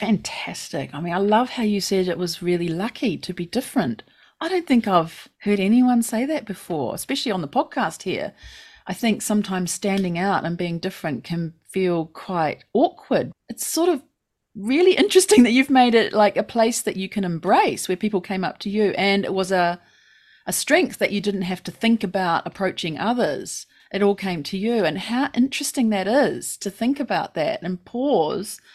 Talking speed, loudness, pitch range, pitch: 195 wpm, -22 LUFS, 185-245 Hz, 205 Hz